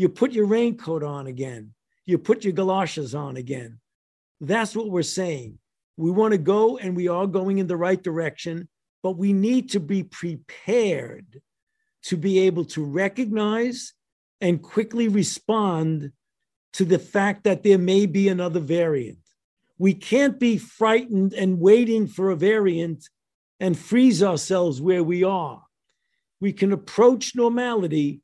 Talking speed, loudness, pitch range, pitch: 150 wpm, -22 LUFS, 170-215 Hz, 190 Hz